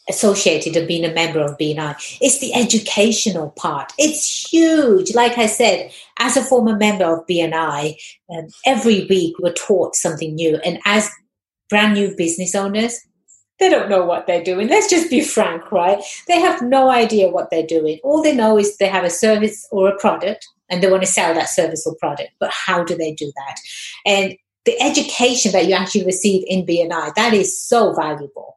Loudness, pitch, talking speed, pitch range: -16 LUFS, 195 Hz, 195 wpm, 170-230 Hz